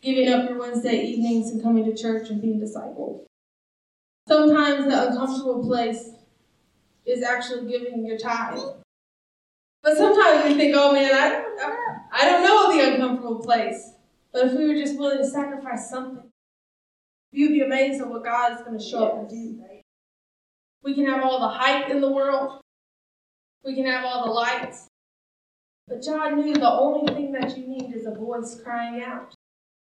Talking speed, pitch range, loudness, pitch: 175 wpm, 235-275 Hz, -22 LUFS, 255 Hz